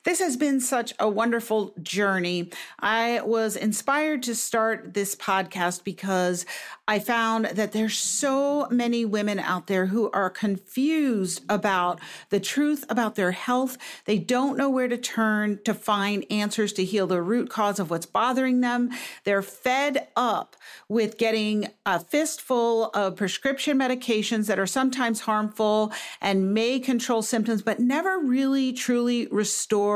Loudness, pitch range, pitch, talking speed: -25 LUFS, 200-250 Hz, 220 Hz, 150 wpm